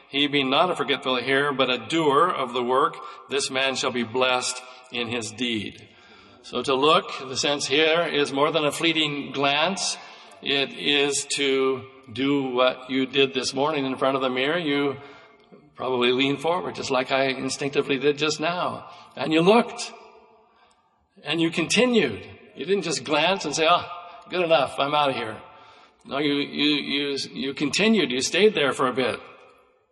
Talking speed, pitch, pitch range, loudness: 175 wpm, 140 Hz, 130-160 Hz, -23 LUFS